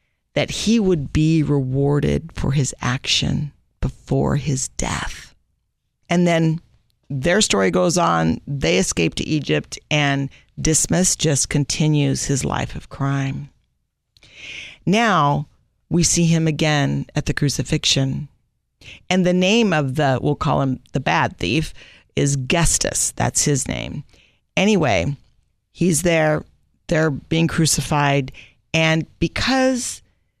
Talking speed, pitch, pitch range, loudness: 120 wpm, 145 Hz, 135-165 Hz, -19 LUFS